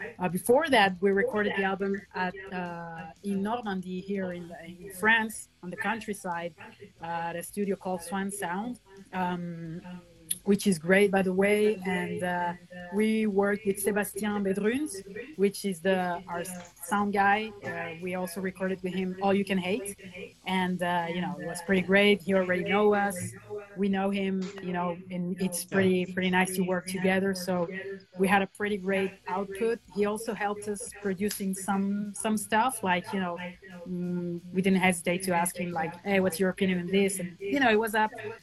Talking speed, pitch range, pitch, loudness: 185 wpm, 180-200 Hz, 190 Hz, -29 LUFS